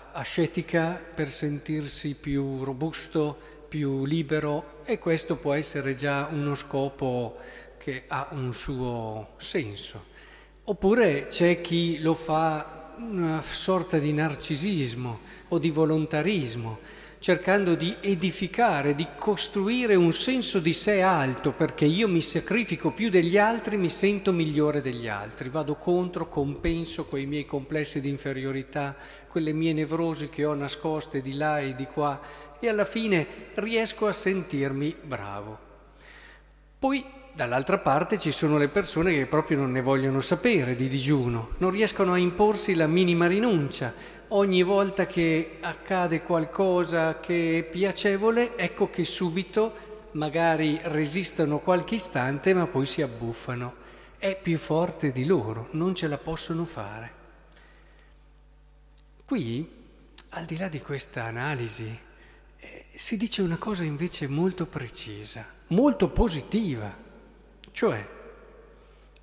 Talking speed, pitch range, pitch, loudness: 130 wpm, 145-185 Hz, 160 Hz, -26 LUFS